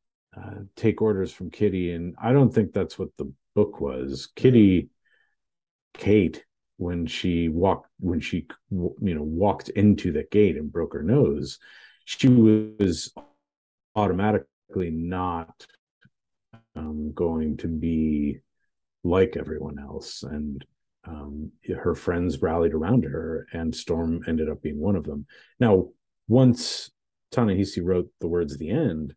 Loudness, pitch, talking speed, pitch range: -25 LUFS, 85 Hz, 135 wpm, 80-105 Hz